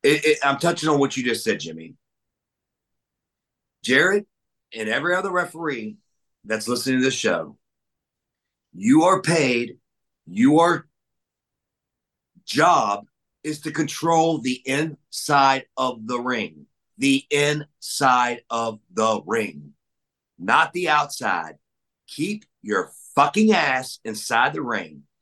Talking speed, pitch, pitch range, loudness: 115 wpm, 140 Hz, 125-165 Hz, -21 LUFS